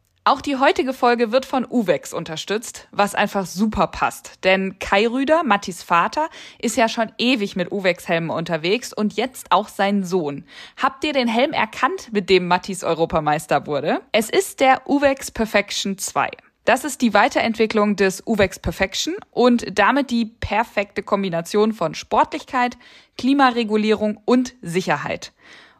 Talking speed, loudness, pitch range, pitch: 145 wpm, -20 LUFS, 195-255 Hz, 215 Hz